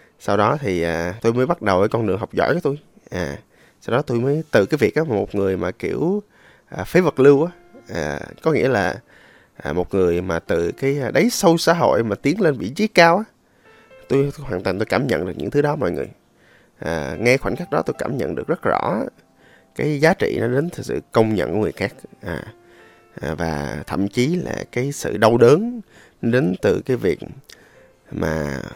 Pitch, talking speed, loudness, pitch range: 115 Hz, 215 wpm, -20 LUFS, 90-150 Hz